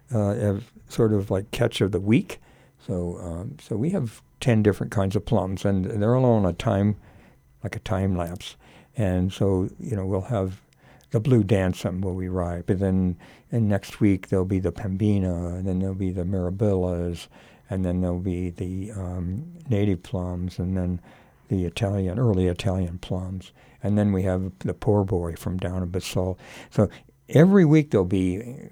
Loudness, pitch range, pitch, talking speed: -25 LUFS, 90-110 Hz, 95 Hz, 180 wpm